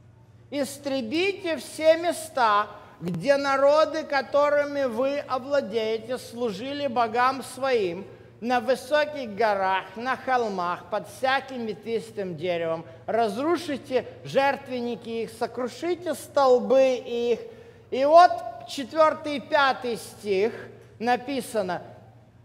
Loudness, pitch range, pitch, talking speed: -25 LUFS, 225-290 Hz, 255 Hz, 85 wpm